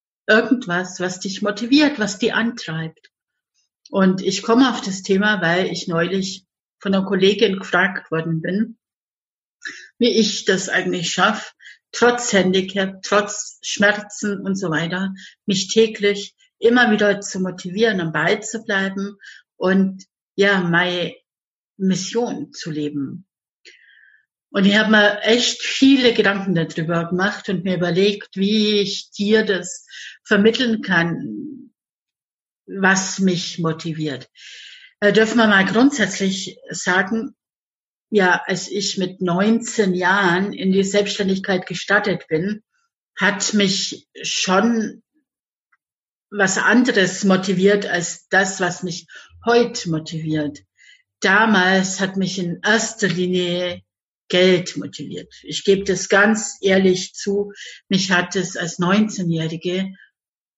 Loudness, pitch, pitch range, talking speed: -19 LUFS, 195 Hz, 180-215 Hz, 115 wpm